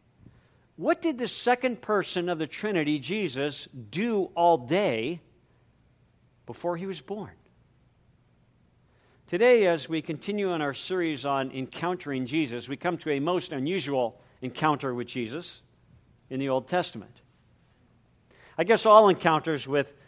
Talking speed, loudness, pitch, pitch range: 130 wpm, -27 LUFS, 160 Hz, 135-185 Hz